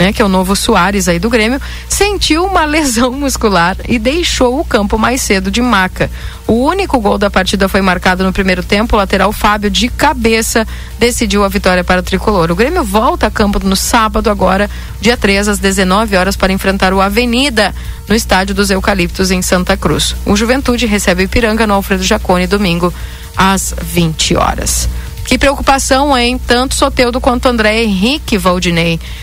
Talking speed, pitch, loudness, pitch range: 180 wpm, 210 Hz, -11 LUFS, 190-245 Hz